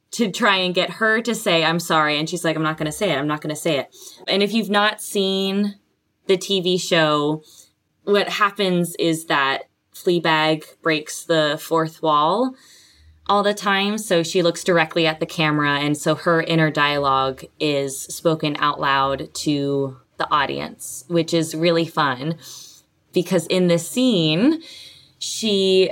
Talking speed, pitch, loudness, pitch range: 165 wpm, 165 Hz, -20 LUFS, 155-195 Hz